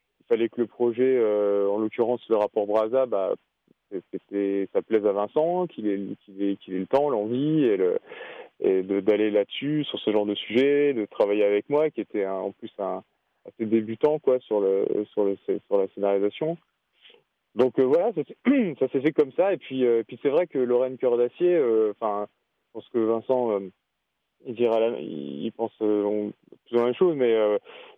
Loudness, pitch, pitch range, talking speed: -25 LUFS, 115 Hz, 105-145 Hz, 205 wpm